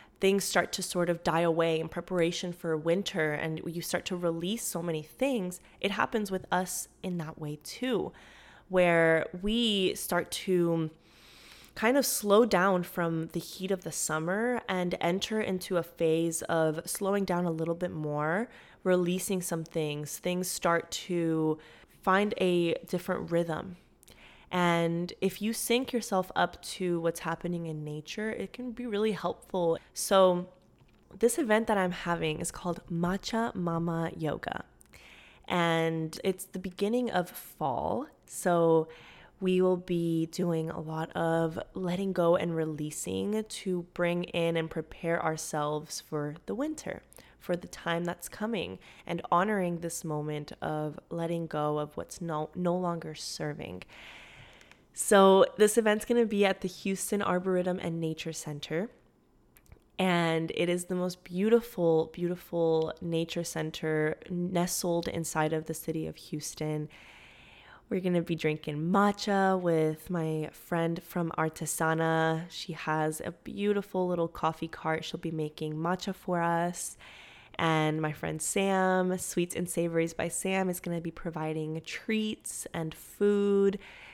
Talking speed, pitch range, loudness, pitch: 145 wpm, 160-185 Hz, -30 LUFS, 170 Hz